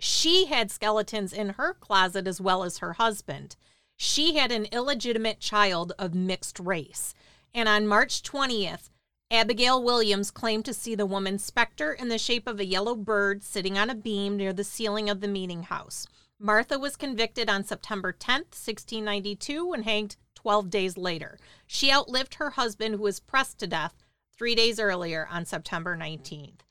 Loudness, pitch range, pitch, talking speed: -27 LUFS, 195-235 Hz, 210 Hz, 170 wpm